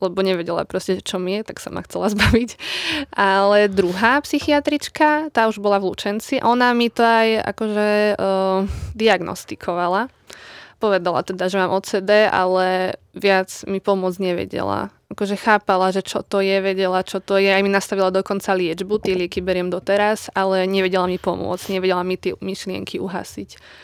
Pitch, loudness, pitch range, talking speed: 195 Hz, -19 LUFS, 185-210 Hz, 160 wpm